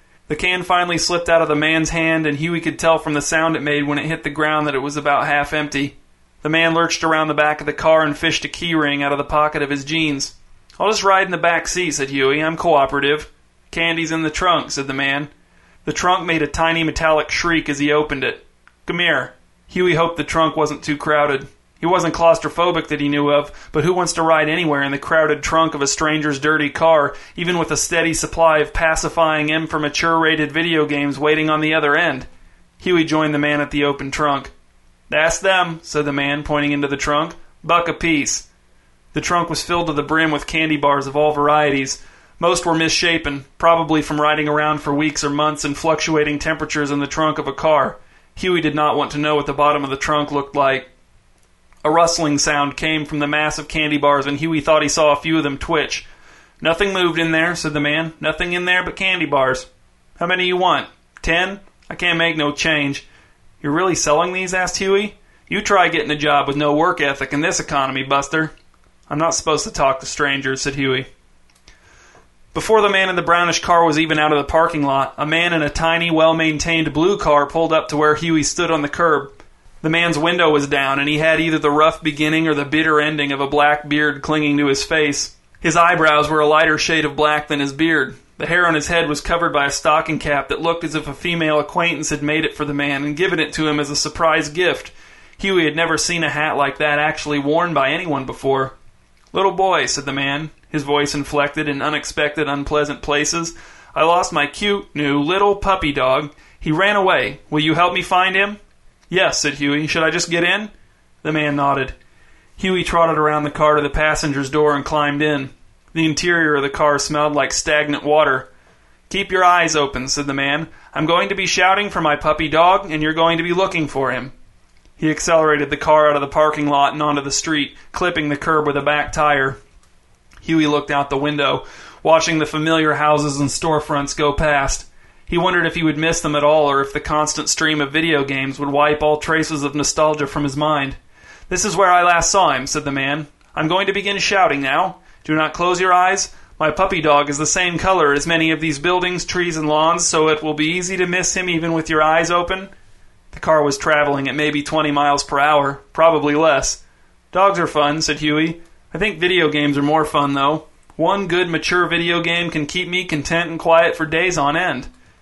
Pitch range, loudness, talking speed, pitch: 145-165 Hz, -17 LUFS, 220 wpm, 155 Hz